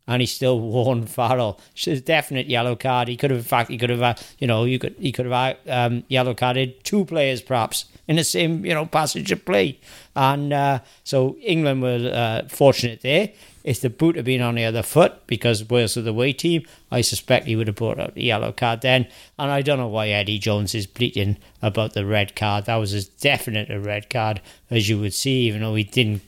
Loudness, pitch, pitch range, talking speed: -21 LUFS, 125 Hz, 110-135 Hz, 235 wpm